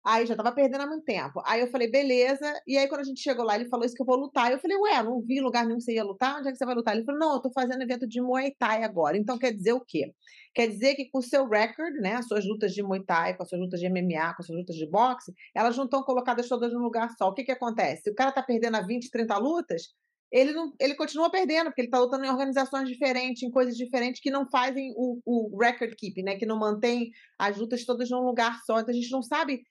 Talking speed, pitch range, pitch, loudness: 290 wpm, 230-270 Hz, 250 Hz, -28 LUFS